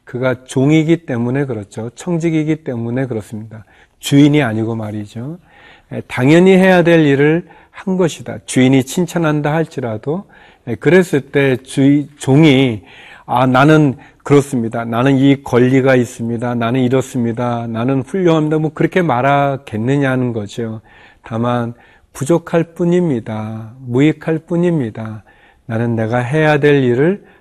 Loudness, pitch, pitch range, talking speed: -14 LUFS, 135 Hz, 120-155 Hz, 290 characters per minute